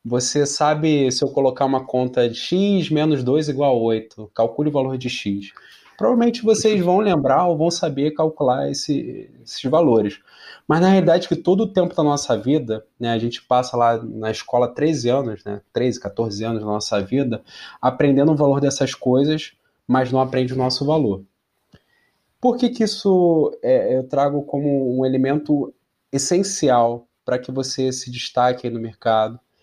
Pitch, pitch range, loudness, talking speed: 135 Hz, 120-155 Hz, -19 LUFS, 180 wpm